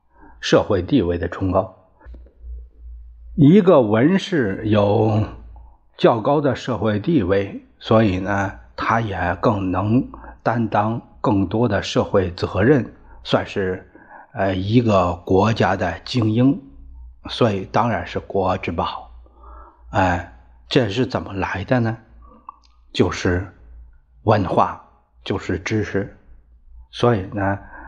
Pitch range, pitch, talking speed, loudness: 70-110 Hz, 95 Hz, 155 characters per minute, -20 LUFS